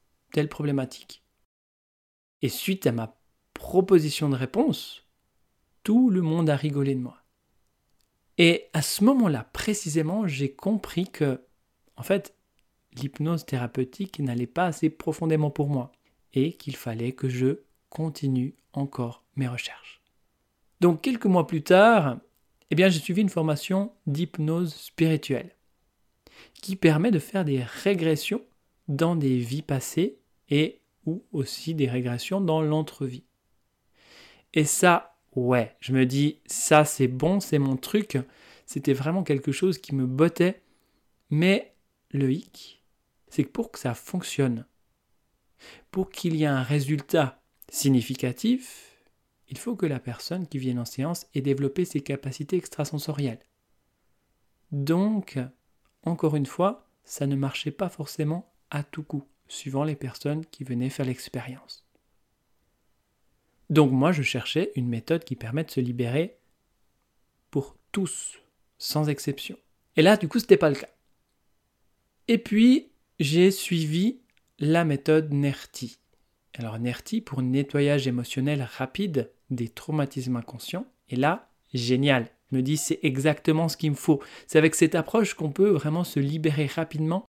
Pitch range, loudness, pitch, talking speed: 130-170 Hz, -26 LUFS, 150 Hz, 140 wpm